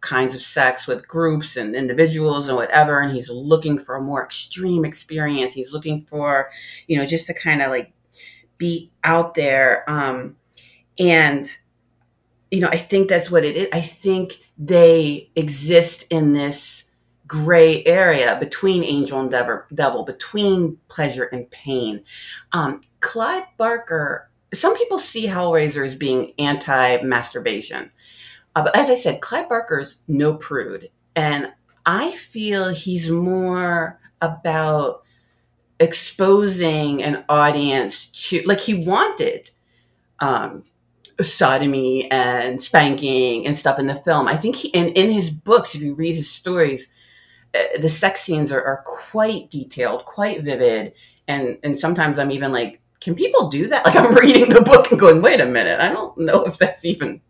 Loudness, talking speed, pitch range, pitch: -18 LUFS, 155 wpm, 135-180 Hz, 155 Hz